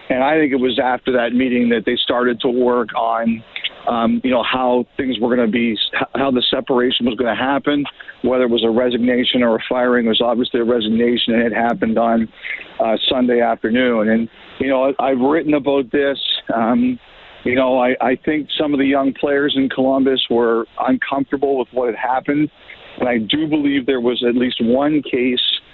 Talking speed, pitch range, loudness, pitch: 200 wpm, 120-135 Hz, -17 LUFS, 125 Hz